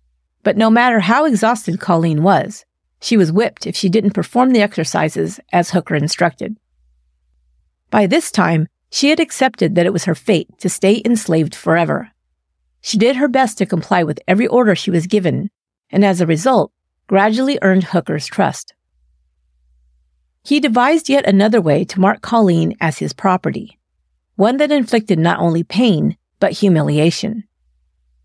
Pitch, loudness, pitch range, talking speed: 185 Hz, -15 LUFS, 150-225 Hz, 155 wpm